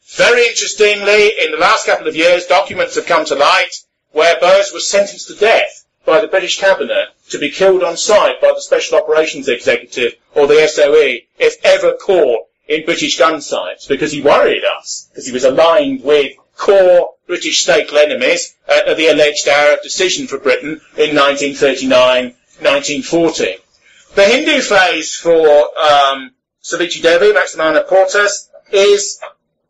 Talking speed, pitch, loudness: 150 wpm, 200 Hz, -12 LUFS